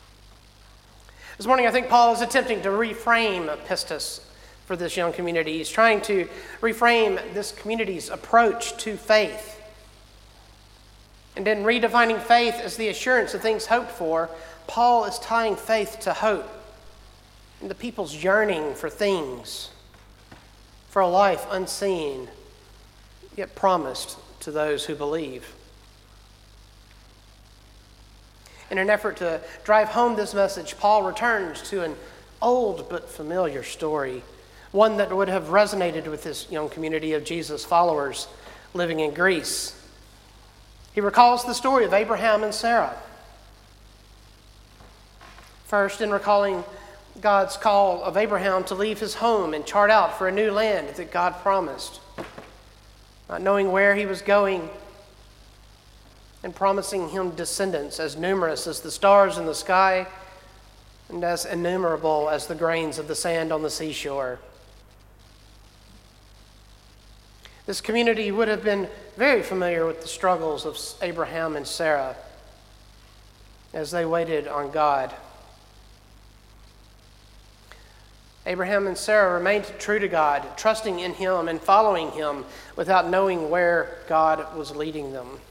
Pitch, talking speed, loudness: 170 Hz, 130 wpm, -23 LUFS